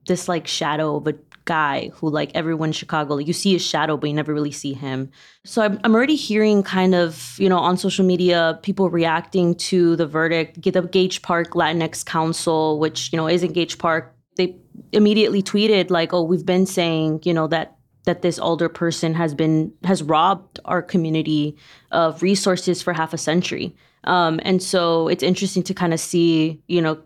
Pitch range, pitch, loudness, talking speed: 160-185 Hz, 170 Hz, -20 LUFS, 195 wpm